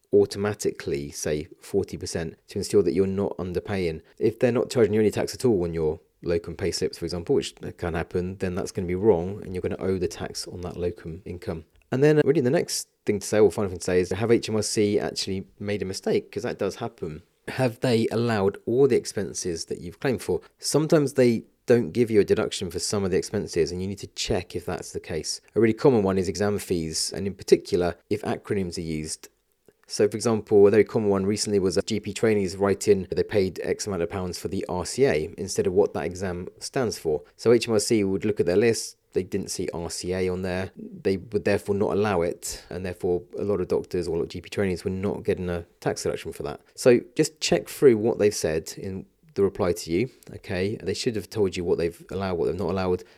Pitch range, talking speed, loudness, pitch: 90-125 Hz, 235 wpm, -25 LUFS, 100 Hz